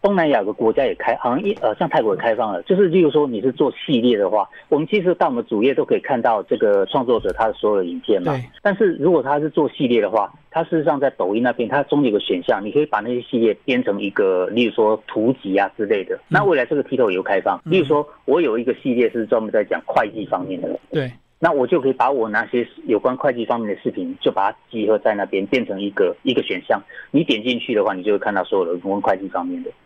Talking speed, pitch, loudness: 380 characters per minute, 210 Hz, -19 LUFS